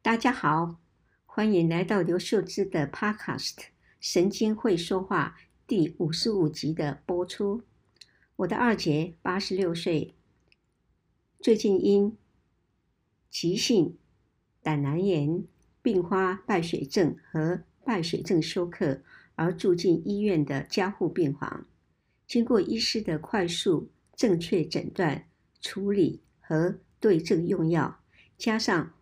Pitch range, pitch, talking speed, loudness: 165-205 Hz, 185 Hz, 180 characters per minute, -27 LUFS